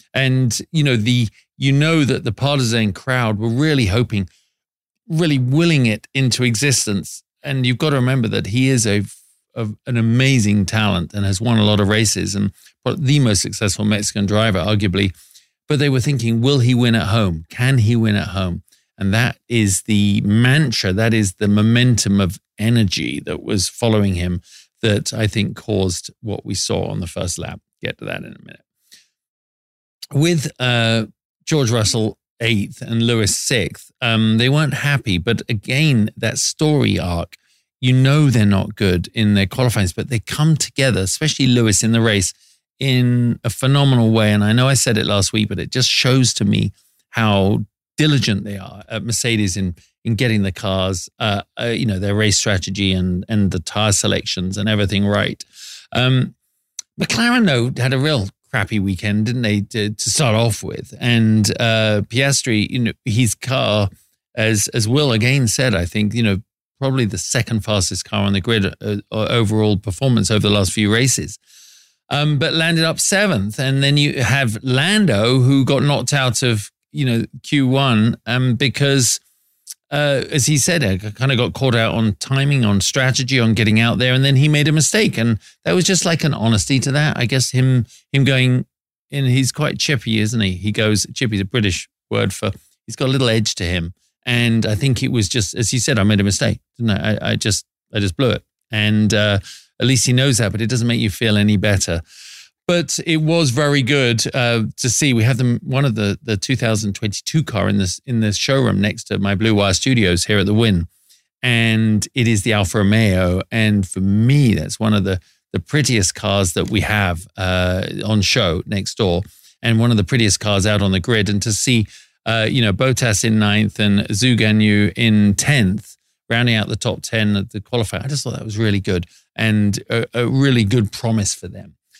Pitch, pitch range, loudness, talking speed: 115 Hz, 105-130 Hz, -17 LUFS, 195 wpm